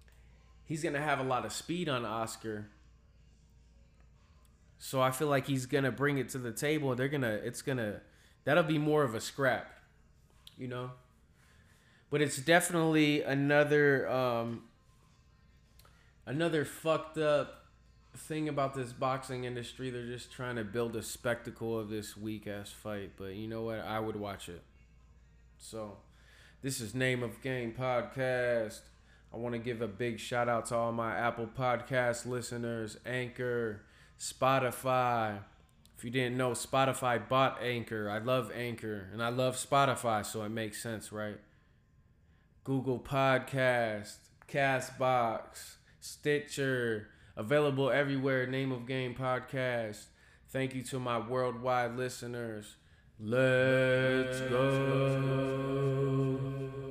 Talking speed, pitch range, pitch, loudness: 130 wpm, 110-135 Hz, 125 Hz, -33 LUFS